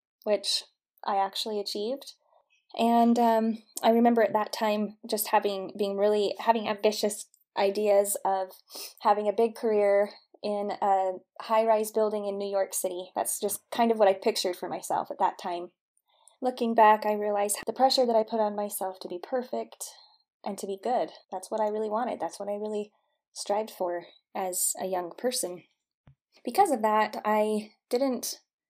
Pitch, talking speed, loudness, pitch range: 210 Hz, 170 wpm, -28 LUFS, 200-225 Hz